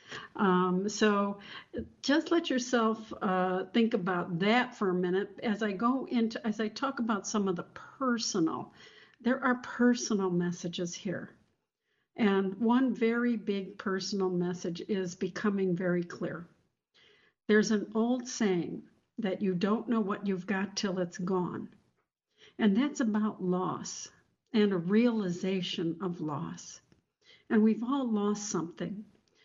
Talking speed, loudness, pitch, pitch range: 135 wpm, -31 LUFS, 205 Hz, 185-235 Hz